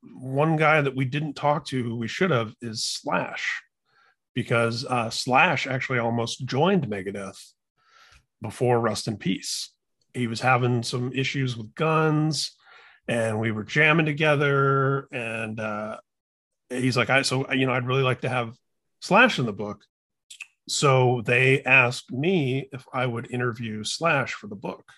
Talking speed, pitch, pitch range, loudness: 155 wpm, 125 Hz, 115-135 Hz, -24 LUFS